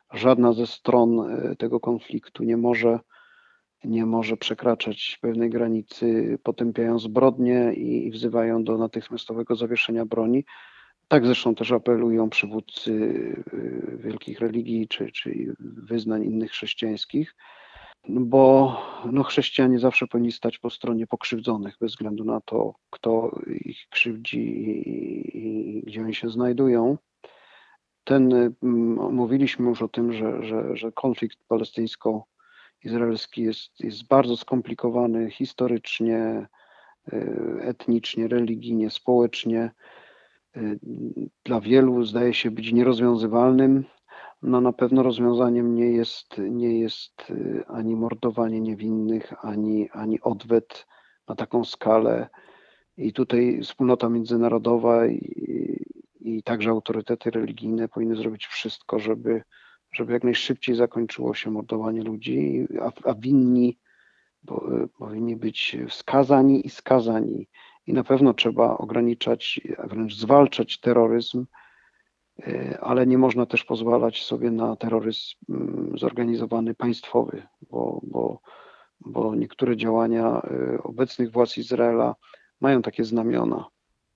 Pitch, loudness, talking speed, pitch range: 115 Hz, -24 LUFS, 110 wpm, 115-120 Hz